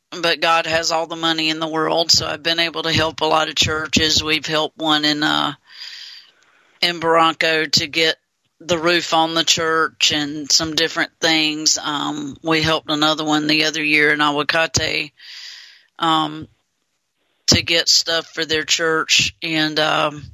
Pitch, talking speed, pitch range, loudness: 160 Hz, 165 wpm, 155-165 Hz, -17 LUFS